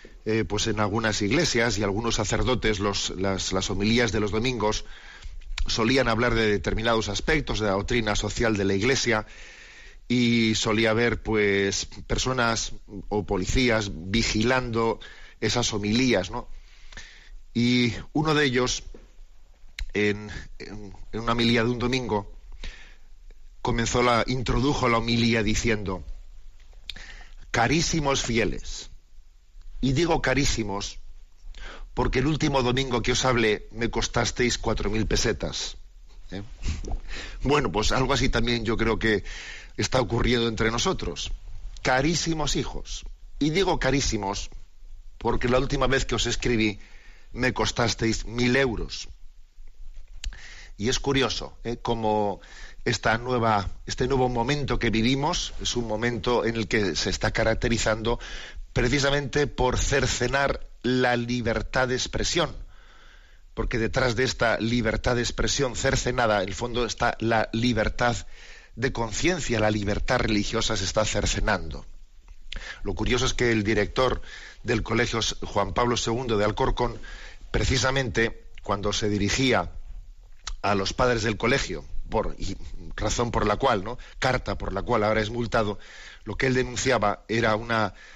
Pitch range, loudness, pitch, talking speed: 100-125 Hz, -25 LUFS, 110 Hz, 130 wpm